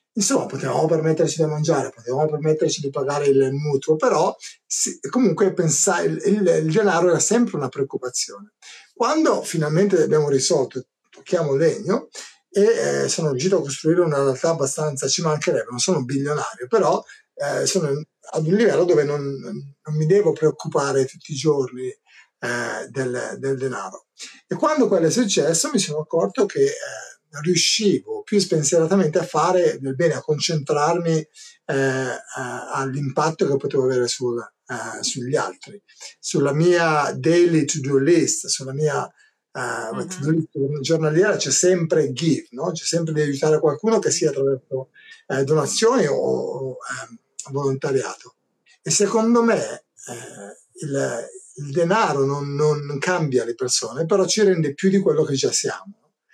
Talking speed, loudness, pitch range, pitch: 150 wpm, -20 LUFS, 140-185 Hz, 155 Hz